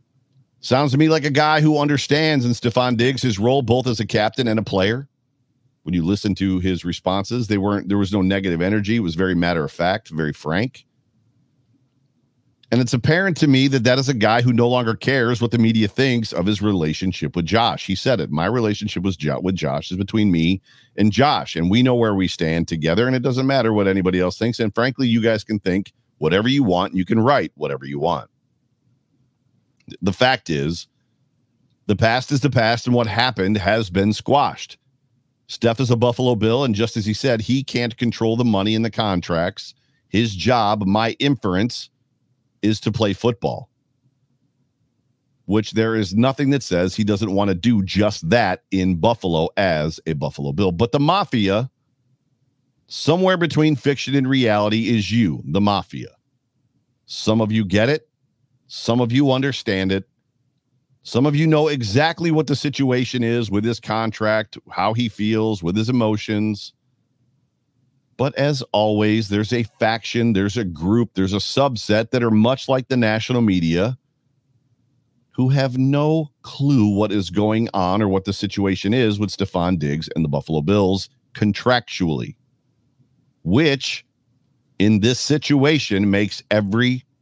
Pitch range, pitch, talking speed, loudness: 105-130 Hz, 120 Hz, 175 wpm, -19 LUFS